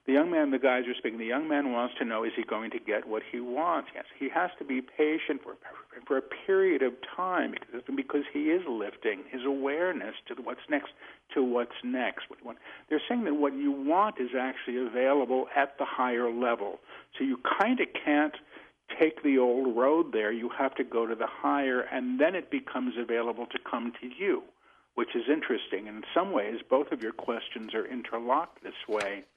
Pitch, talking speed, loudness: 135 Hz, 210 wpm, -30 LUFS